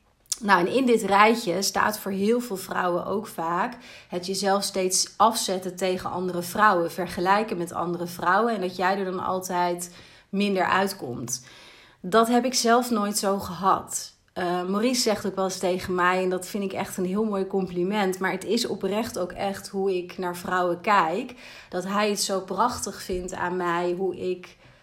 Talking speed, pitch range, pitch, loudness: 185 wpm, 180-205 Hz, 190 Hz, -25 LUFS